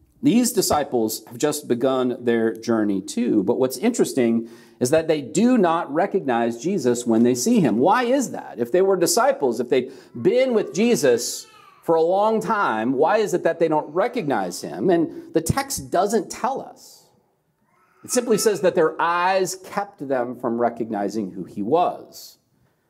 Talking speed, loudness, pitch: 170 wpm, -21 LUFS, 165 Hz